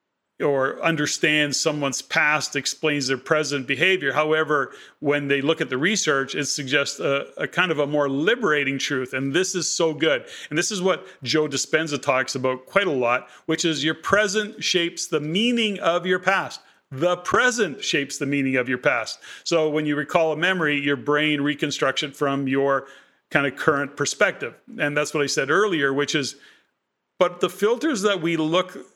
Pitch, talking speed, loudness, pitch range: 150 Hz, 185 wpm, -22 LUFS, 140-170 Hz